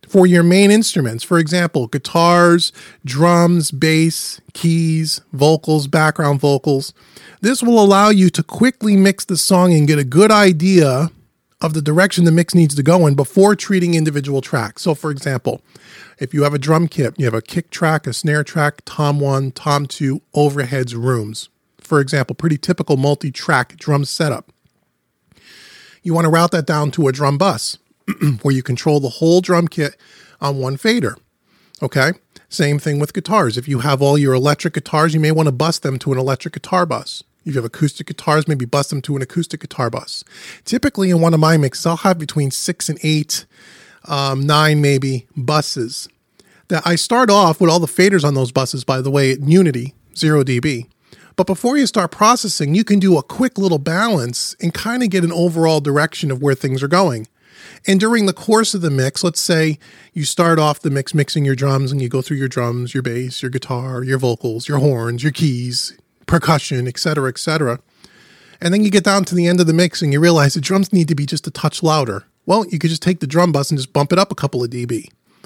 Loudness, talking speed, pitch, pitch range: -16 LUFS, 210 wpm, 155 Hz, 140-175 Hz